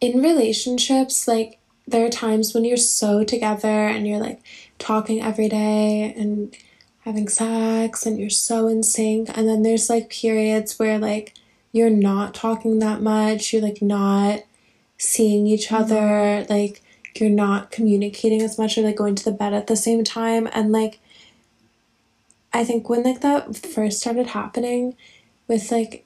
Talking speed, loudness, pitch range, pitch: 160 wpm, -20 LUFS, 210-230 Hz, 220 Hz